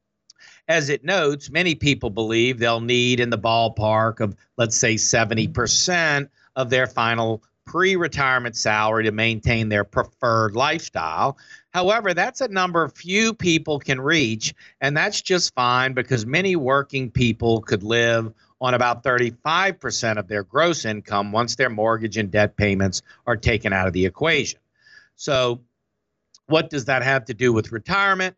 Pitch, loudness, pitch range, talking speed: 125 Hz, -21 LUFS, 110-145 Hz, 150 wpm